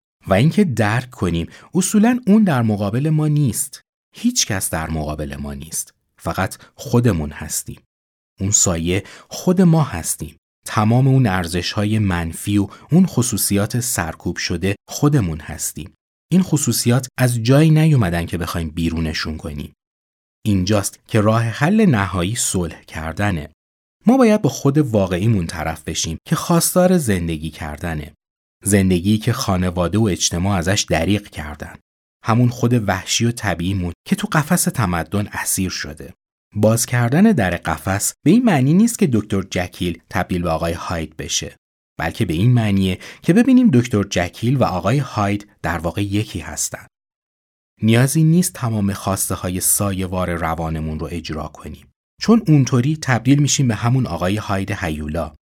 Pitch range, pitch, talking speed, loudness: 85-125 Hz, 100 Hz, 145 wpm, -18 LUFS